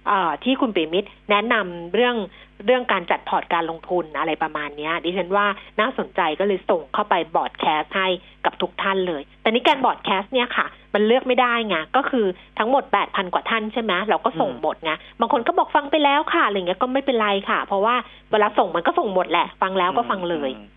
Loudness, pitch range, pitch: -21 LUFS, 180-245 Hz, 205 Hz